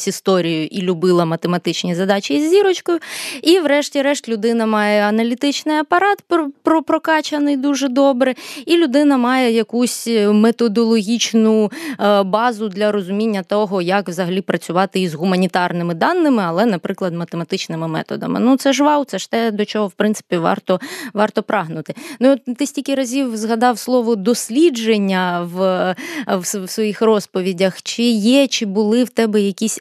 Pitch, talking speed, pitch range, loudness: 225 Hz, 140 wpm, 195-275 Hz, -17 LUFS